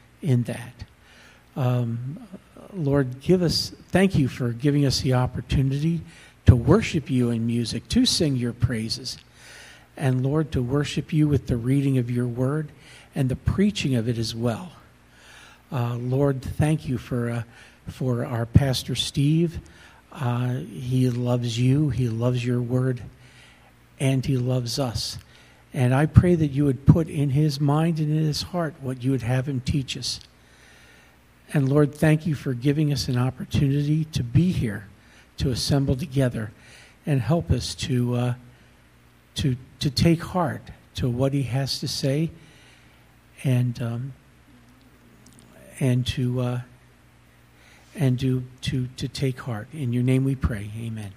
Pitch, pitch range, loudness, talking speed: 130 Hz, 115-145 Hz, -24 LUFS, 150 wpm